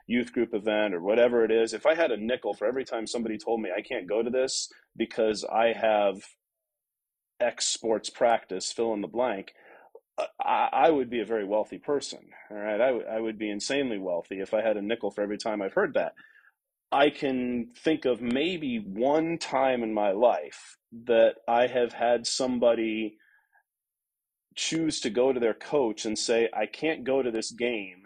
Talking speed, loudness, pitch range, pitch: 195 wpm, -27 LUFS, 110-135 Hz, 120 Hz